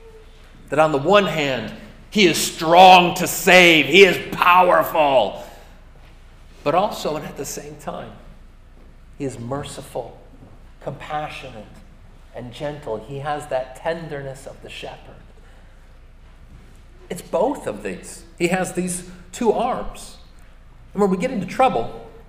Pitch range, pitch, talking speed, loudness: 135-180 Hz, 155 Hz, 130 wpm, -17 LUFS